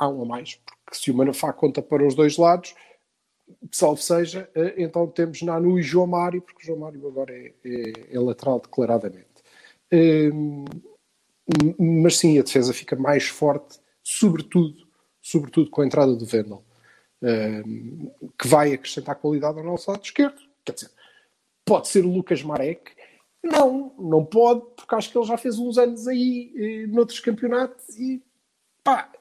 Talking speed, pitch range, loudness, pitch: 160 wpm, 140-220 Hz, -22 LUFS, 165 Hz